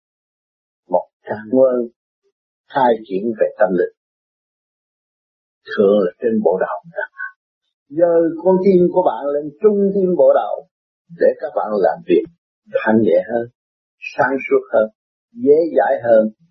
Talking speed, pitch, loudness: 130 wpm, 215 Hz, -17 LUFS